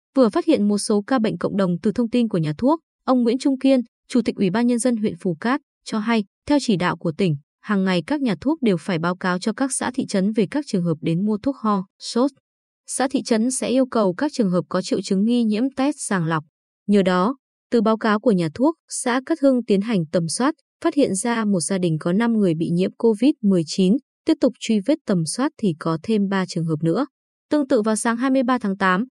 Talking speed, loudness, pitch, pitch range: 250 wpm, -21 LUFS, 225 Hz, 190-260 Hz